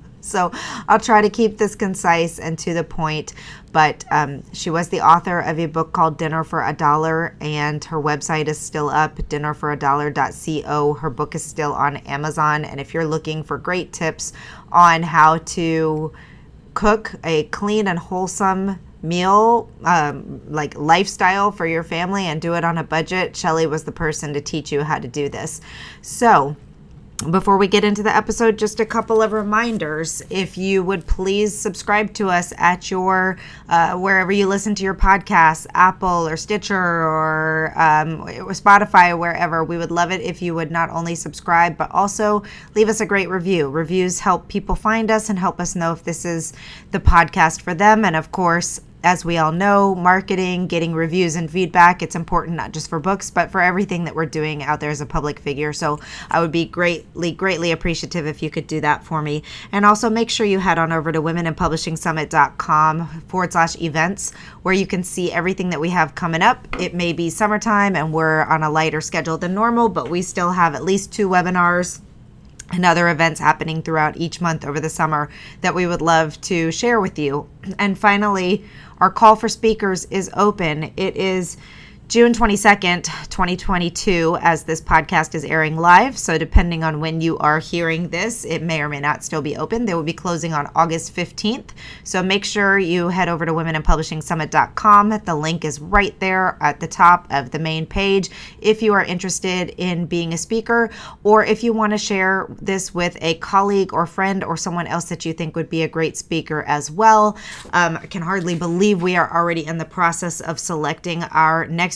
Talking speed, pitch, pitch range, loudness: 195 wpm, 170 Hz, 160-190 Hz, -18 LUFS